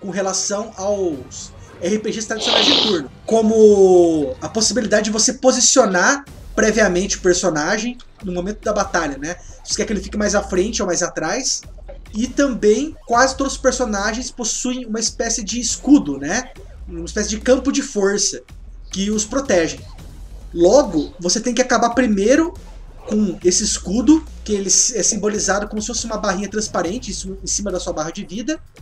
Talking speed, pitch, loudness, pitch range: 165 wpm, 210 Hz, -17 LUFS, 185-240 Hz